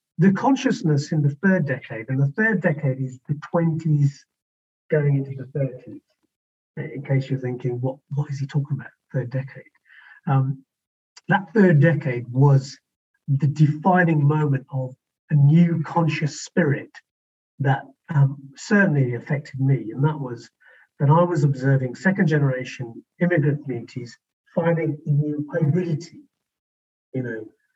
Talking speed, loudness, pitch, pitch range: 140 wpm, -22 LUFS, 145 Hz, 130-165 Hz